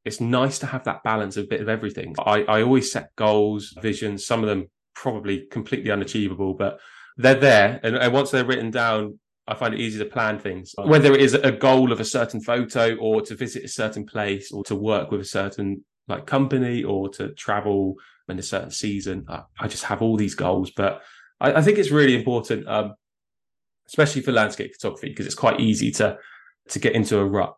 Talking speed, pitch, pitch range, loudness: 215 wpm, 110 Hz, 100-130 Hz, -22 LUFS